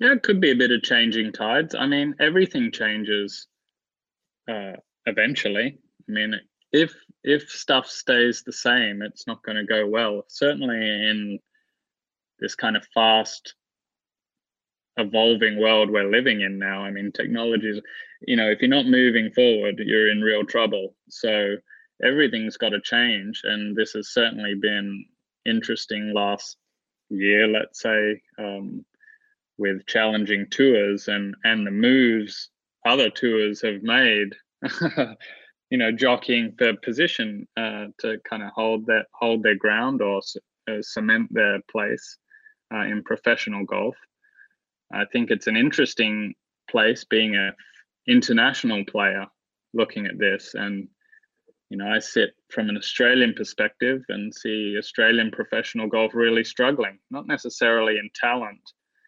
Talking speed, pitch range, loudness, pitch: 140 wpm, 105-120 Hz, -22 LUFS, 110 Hz